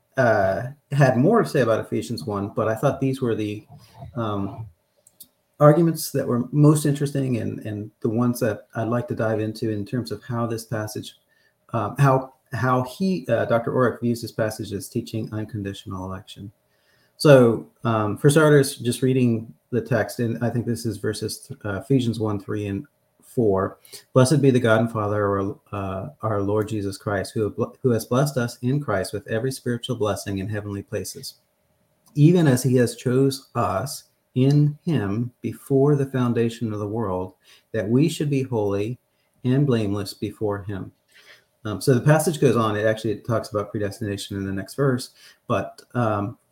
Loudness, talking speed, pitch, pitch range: -23 LUFS, 180 wpm, 115 Hz, 105-130 Hz